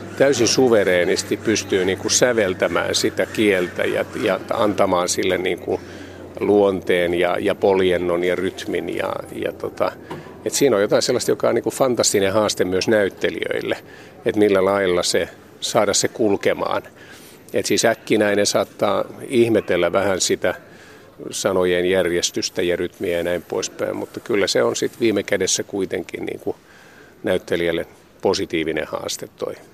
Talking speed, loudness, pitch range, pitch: 135 wpm, -20 LUFS, 90-100 Hz, 95 Hz